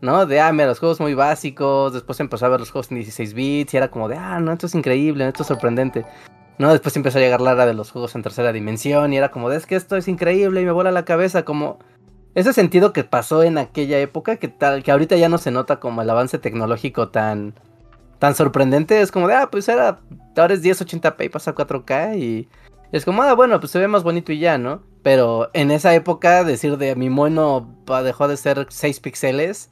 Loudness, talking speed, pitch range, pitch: -18 LUFS, 240 wpm, 130-170 Hz, 145 Hz